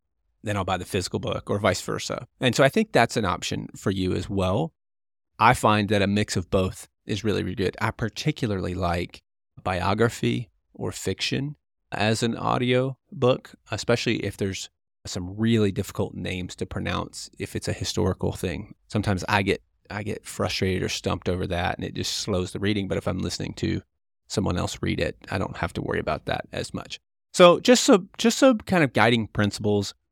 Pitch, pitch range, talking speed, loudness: 105 Hz, 90-115 Hz, 195 wpm, -25 LUFS